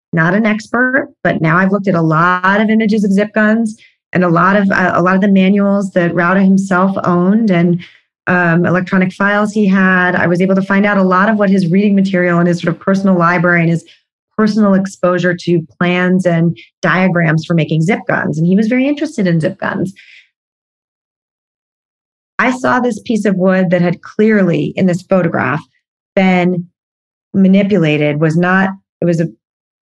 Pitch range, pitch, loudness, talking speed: 175-205 Hz, 185 Hz, -12 LUFS, 185 wpm